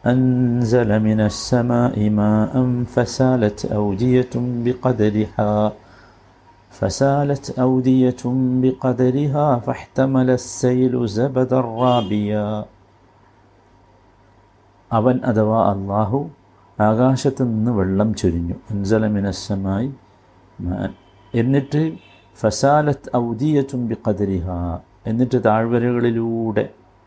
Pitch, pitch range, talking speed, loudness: 115 Hz, 100-125 Hz, 65 wpm, -19 LUFS